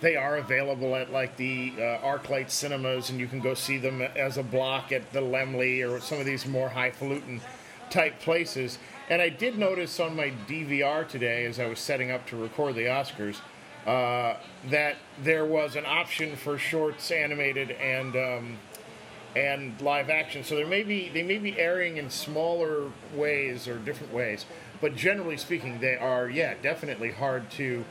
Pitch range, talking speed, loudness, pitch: 130-150 Hz, 180 wpm, -29 LUFS, 135 Hz